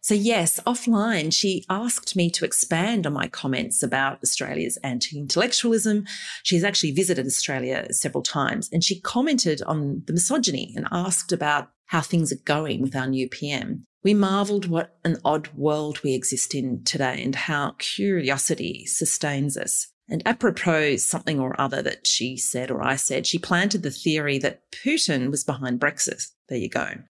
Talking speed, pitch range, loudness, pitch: 170 wpm, 135-195 Hz, -23 LUFS, 160 Hz